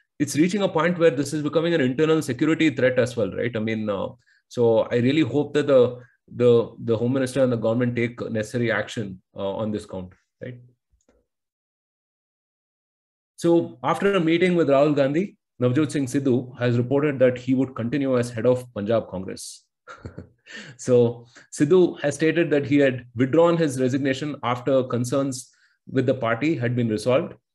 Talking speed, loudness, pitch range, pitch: 170 wpm, -22 LUFS, 120-150 Hz, 130 Hz